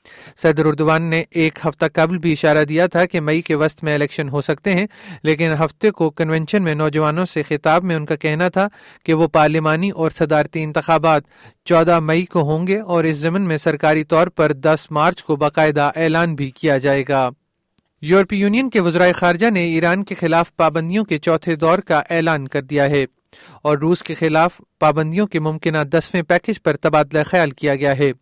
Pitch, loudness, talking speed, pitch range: 160 Hz, -17 LUFS, 195 wpm, 155-175 Hz